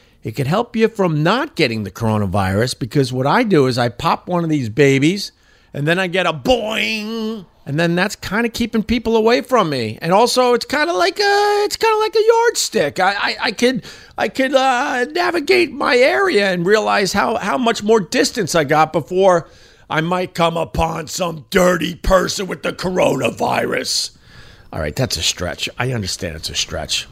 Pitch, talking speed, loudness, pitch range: 185 Hz, 195 wpm, -17 LUFS, 150-240 Hz